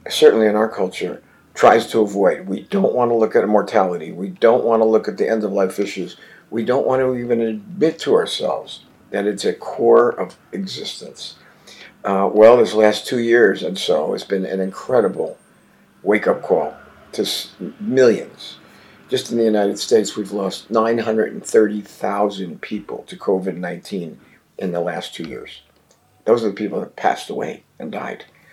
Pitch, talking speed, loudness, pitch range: 110 Hz, 175 wpm, -18 LUFS, 100-115 Hz